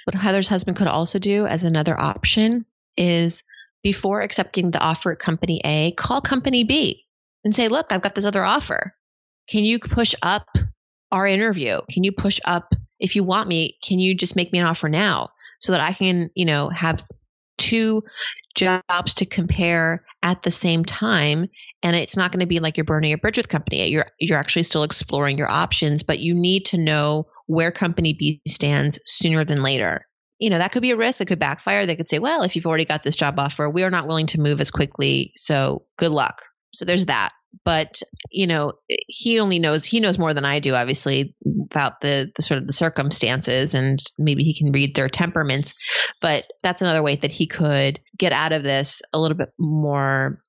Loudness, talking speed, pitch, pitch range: -20 LUFS, 205 wpm, 165 Hz, 150-190 Hz